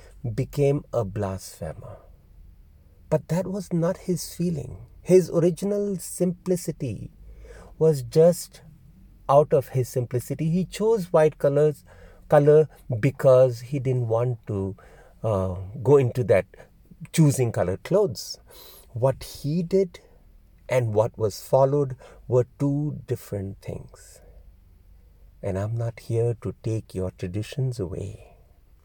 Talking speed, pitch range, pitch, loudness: 115 wpm, 95-150 Hz, 125 Hz, -24 LUFS